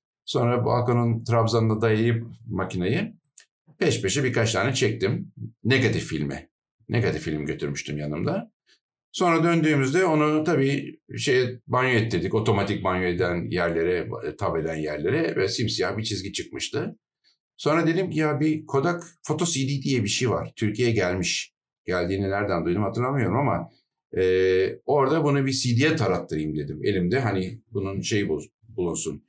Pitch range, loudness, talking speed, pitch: 95-140 Hz, -24 LUFS, 135 wpm, 115 Hz